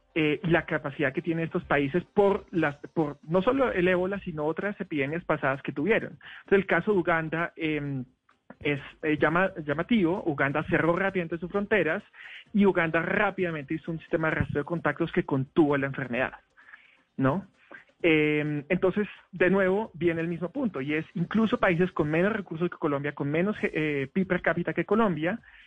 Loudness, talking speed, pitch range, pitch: -27 LUFS, 175 wpm, 150-185 Hz, 170 Hz